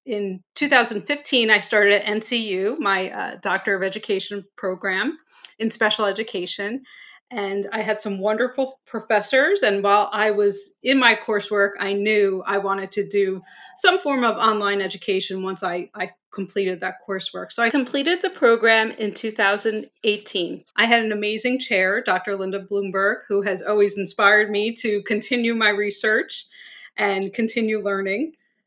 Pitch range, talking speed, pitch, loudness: 195-230 Hz, 150 wpm, 210 Hz, -21 LUFS